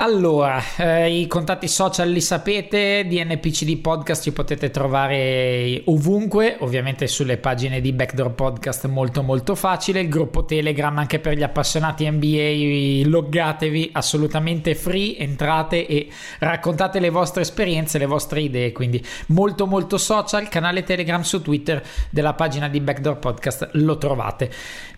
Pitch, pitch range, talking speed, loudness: 155 Hz, 140-175 Hz, 145 wpm, -20 LUFS